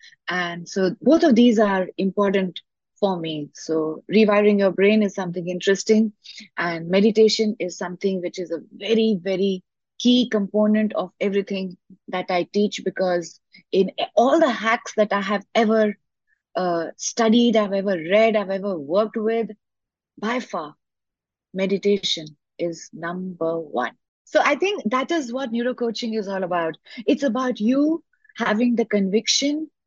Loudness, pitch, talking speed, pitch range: -21 LUFS, 205 Hz, 145 wpm, 185-230 Hz